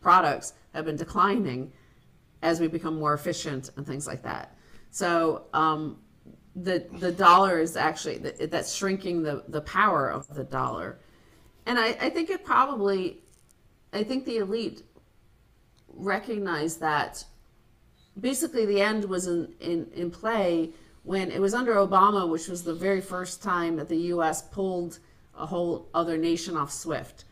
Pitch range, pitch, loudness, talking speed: 160-195 Hz, 175 Hz, -27 LUFS, 155 wpm